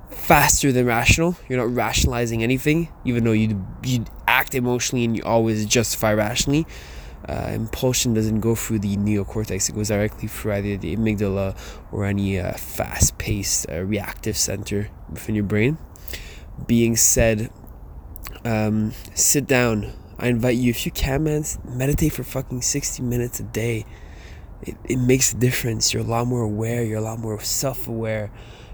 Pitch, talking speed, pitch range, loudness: 110 Hz, 155 wpm, 100-125 Hz, -21 LUFS